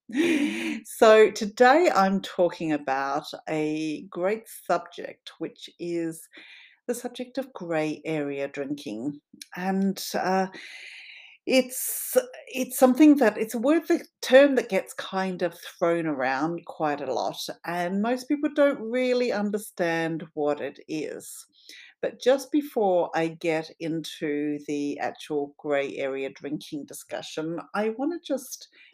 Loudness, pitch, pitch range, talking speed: -26 LUFS, 190 Hz, 155-255 Hz, 125 wpm